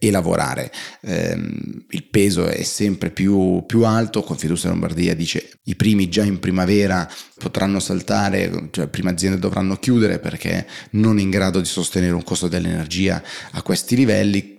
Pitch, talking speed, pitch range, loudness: 95 Hz, 165 wpm, 90-105 Hz, -19 LUFS